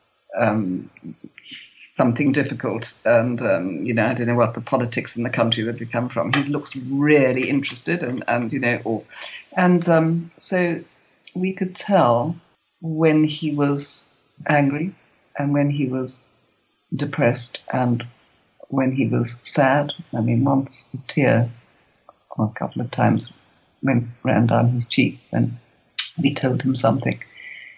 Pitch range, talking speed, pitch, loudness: 120-150 Hz, 145 wpm, 135 Hz, -21 LUFS